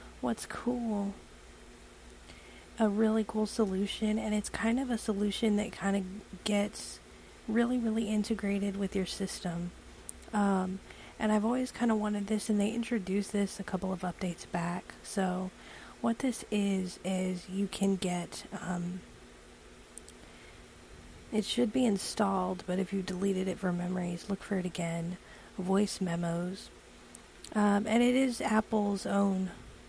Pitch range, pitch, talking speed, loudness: 185-215 Hz, 200 Hz, 145 wpm, -32 LUFS